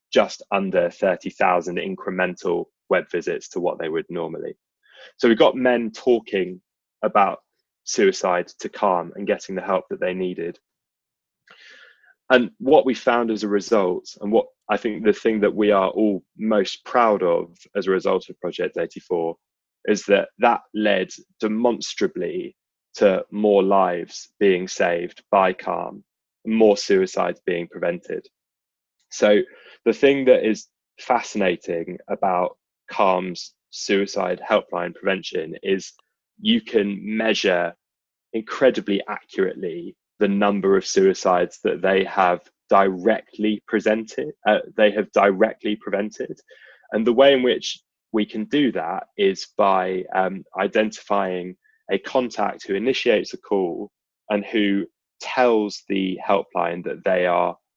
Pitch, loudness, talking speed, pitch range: 105 Hz, -21 LUFS, 135 wpm, 95-130 Hz